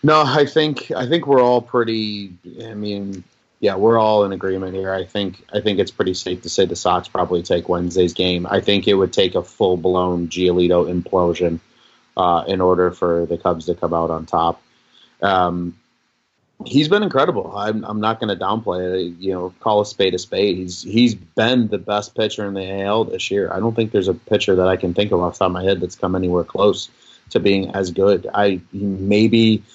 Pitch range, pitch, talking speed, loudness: 90-110 Hz, 95 Hz, 215 wpm, -18 LUFS